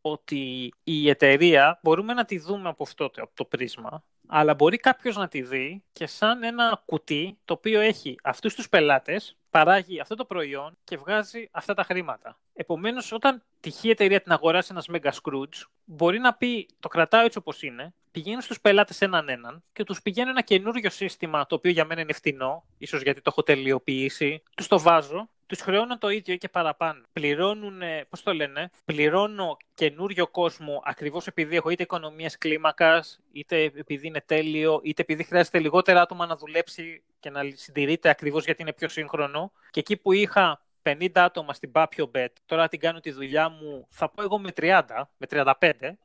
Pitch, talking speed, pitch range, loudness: 165 Hz, 180 wpm, 150-200 Hz, -24 LUFS